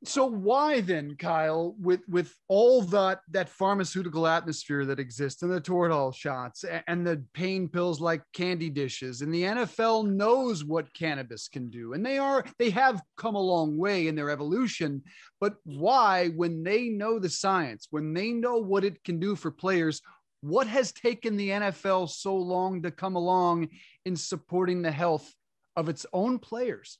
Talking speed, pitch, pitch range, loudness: 175 wpm, 180 Hz, 160-200 Hz, -28 LUFS